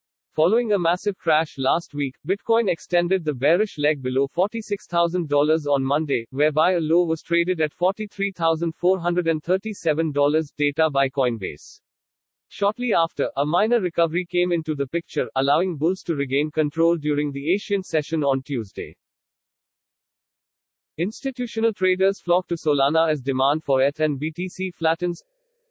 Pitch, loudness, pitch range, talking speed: 165 Hz, -22 LUFS, 145-185 Hz, 135 wpm